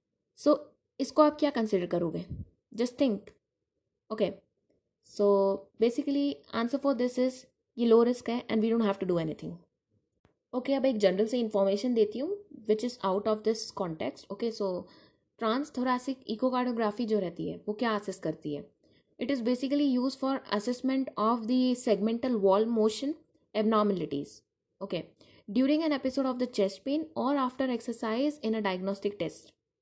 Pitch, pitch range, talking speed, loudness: 230 Hz, 205-265 Hz, 165 wpm, -30 LUFS